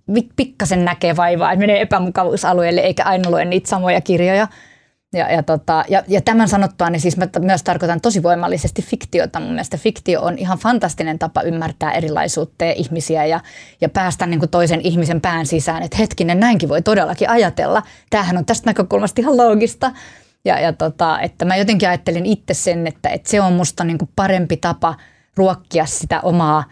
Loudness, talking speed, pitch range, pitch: -16 LUFS, 175 wpm, 165-200 Hz, 180 Hz